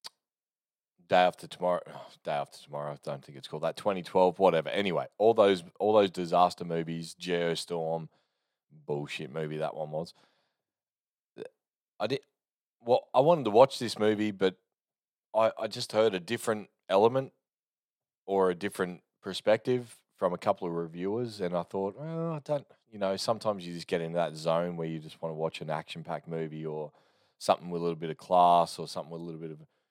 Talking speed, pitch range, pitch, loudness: 185 wpm, 80-105 Hz, 90 Hz, -30 LUFS